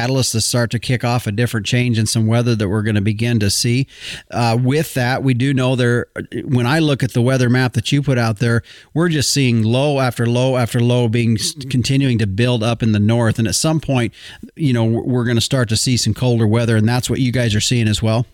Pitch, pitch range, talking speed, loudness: 120 Hz, 115-130 Hz, 255 wpm, -16 LUFS